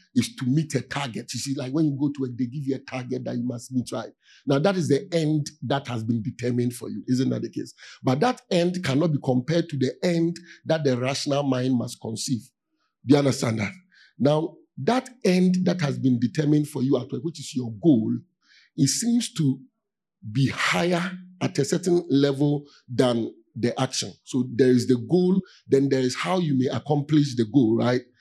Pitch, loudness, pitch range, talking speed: 140 Hz, -24 LUFS, 125-170 Hz, 205 wpm